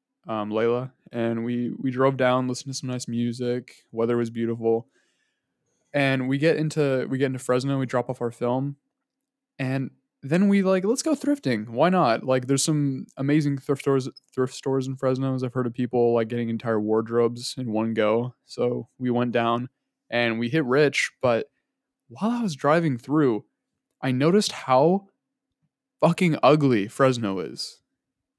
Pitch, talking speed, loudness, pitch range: 130 Hz, 170 wpm, -24 LUFS, 120-150 Hz